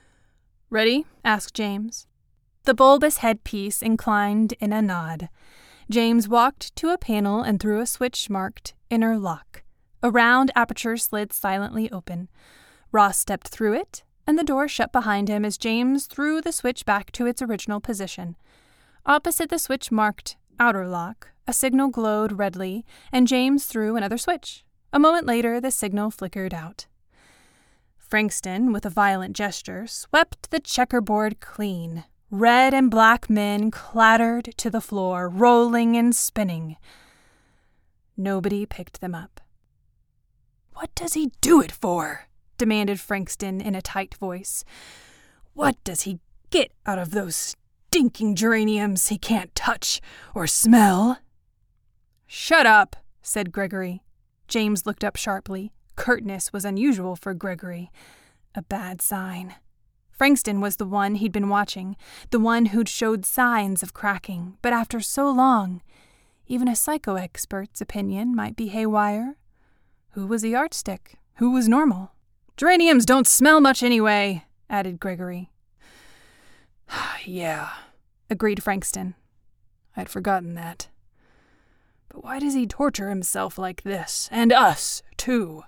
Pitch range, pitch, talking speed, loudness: 195-240 Hz, 210 Hz, 135 wpm, -22 LUFS